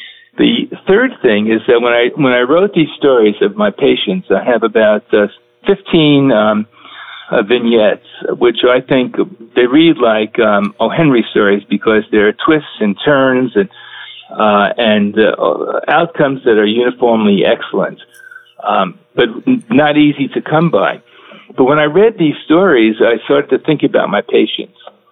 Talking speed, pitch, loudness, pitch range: 160 wpm, 125 Hz, -12 LUFS, 110-160 Hz